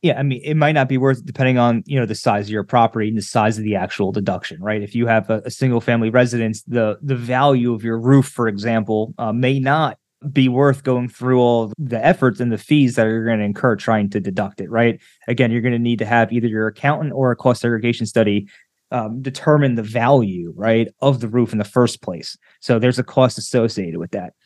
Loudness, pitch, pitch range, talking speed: -18 LUFS, 120 Hz, 110-130 Hz, 245 wpm